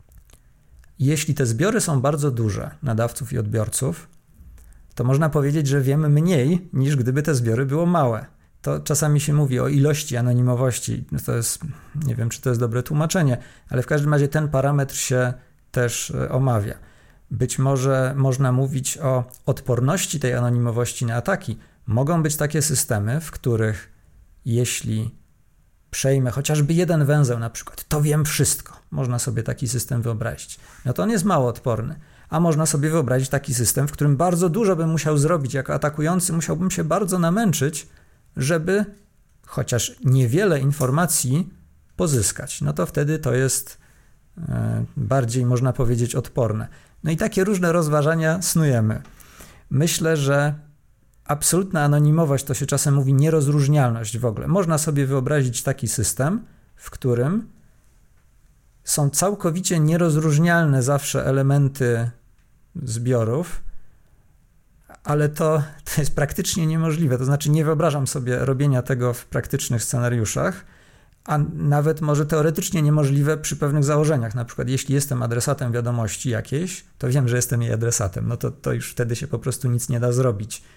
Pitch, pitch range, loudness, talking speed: 140 Hz, 125-155 Hz, -21 LUFS, 145 wpm